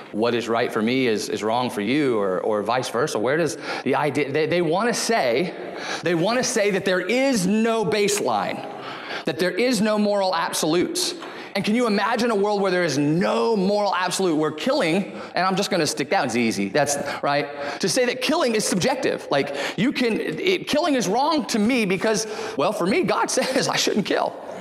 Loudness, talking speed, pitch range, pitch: -22 LUFS, 210 wpm, 165-235 Hz, 205 Hz